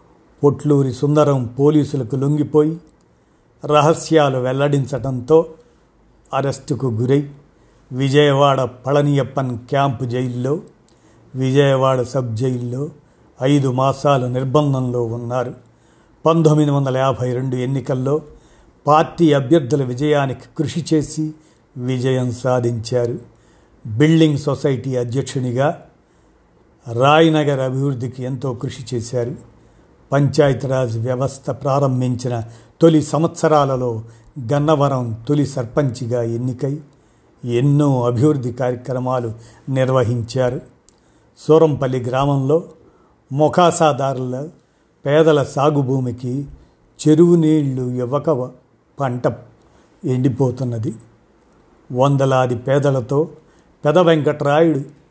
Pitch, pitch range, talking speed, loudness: 135 Hz, 125-150 Hz, 70 wpm, -17 LUFS